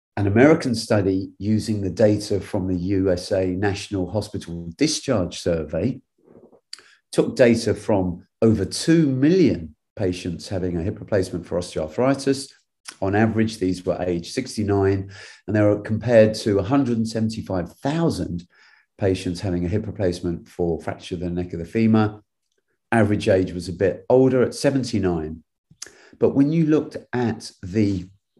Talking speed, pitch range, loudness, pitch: 135 wpm, 90-110 Hz, -22 LUFS, 100 Hz